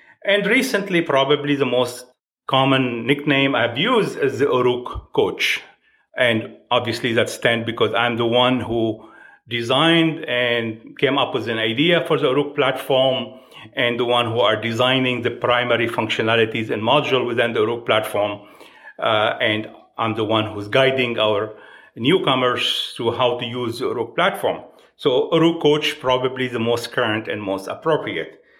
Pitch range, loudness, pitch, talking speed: 115-145 Hz, -19 LUFS, 125 Hz, 155 wpm